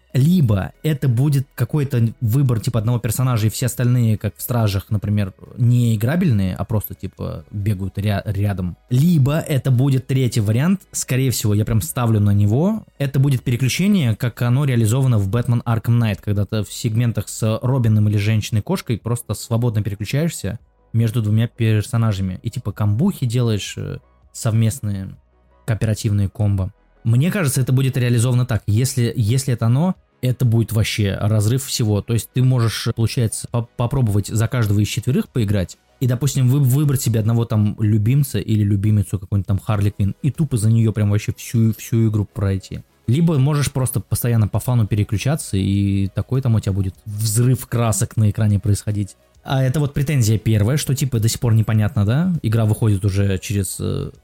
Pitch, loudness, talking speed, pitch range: 115 Hz, -19 LUFS, 165 wpm, 105-130 Hz